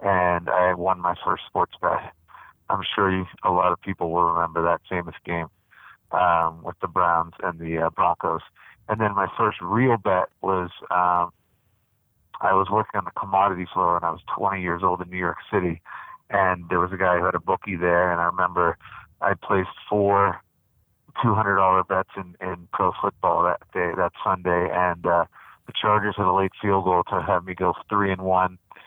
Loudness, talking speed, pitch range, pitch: -23 LUFS, 195 wpm, 90-100 Hz, 90 Hz